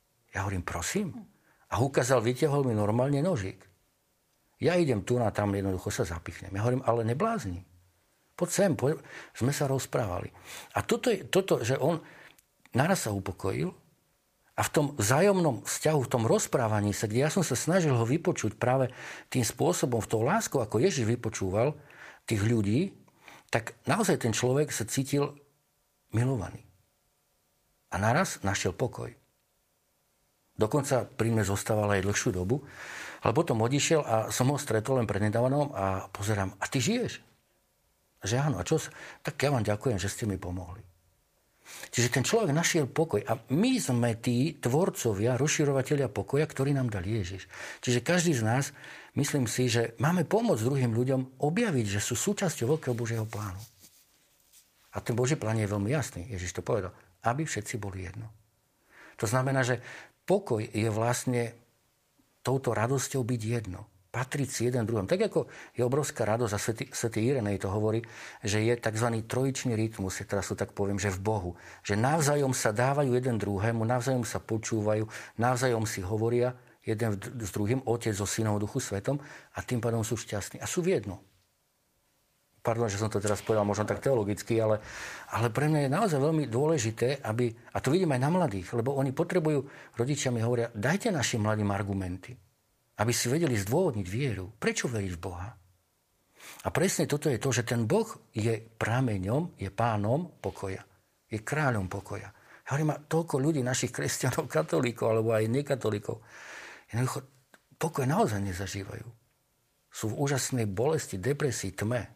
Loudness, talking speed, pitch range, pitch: -29 LUFS, 160 wpm, 105-140 Hz, 120 Hz